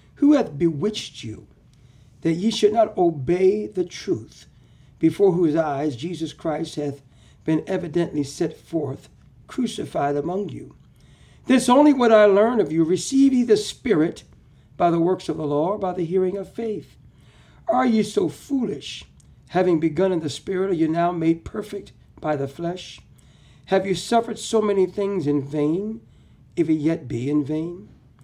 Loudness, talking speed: -22 LUFS, 165 wpm